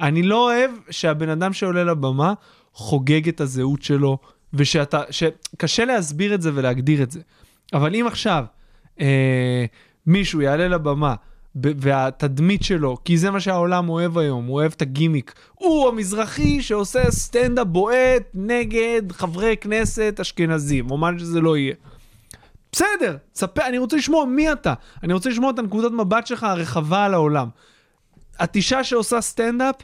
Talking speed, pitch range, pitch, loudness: 145 wpm, 145-225 Hz, 170 Hz, -20 LUFS